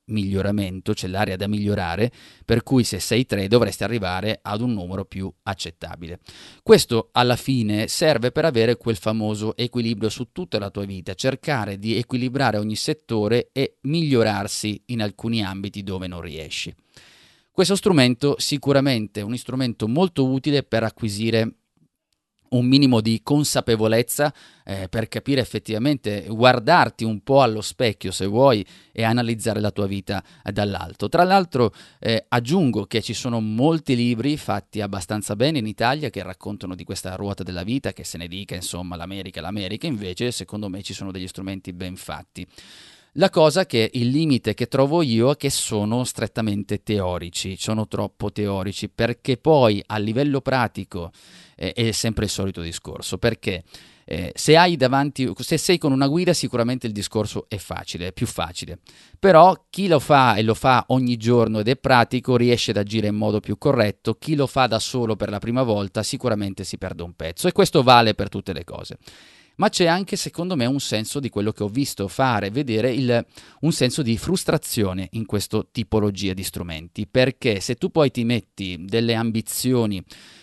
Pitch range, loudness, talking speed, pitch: 100-130 Hz, -21 LUFS, 170 wpm, 115 Hz